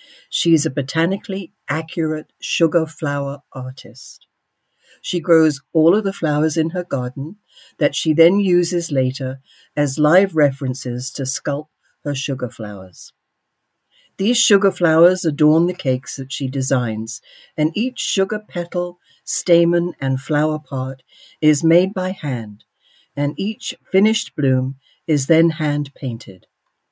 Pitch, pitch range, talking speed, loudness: 155 Hz, 135-175 Hz, 130 wpm, -19 LUFS